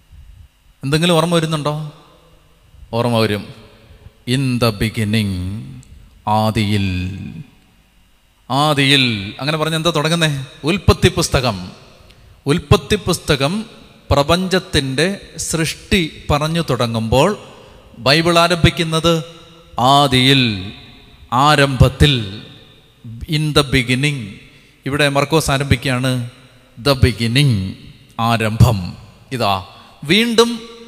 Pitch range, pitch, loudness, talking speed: 110-155 Hz, 135 Hz, -16 LUFS, 70 wpm